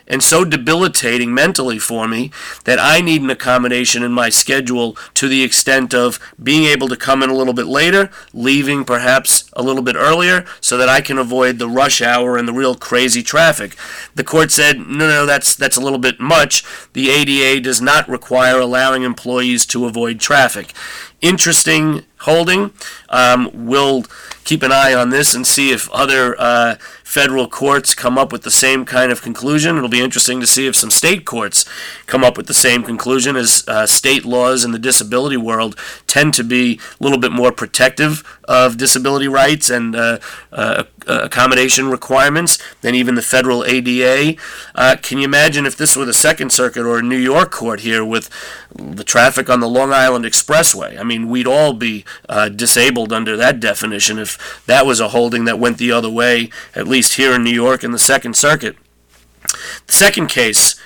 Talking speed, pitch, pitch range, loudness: 190 wpm, 130 Hz, 120-135 Hz, -12 LUFS